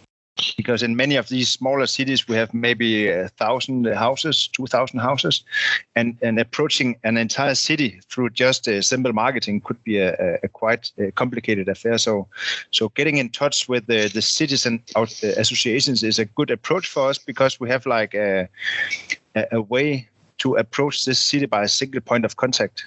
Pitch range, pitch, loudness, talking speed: 110-135 Hz, 120 Hz, -20 LUFS, 175 wpm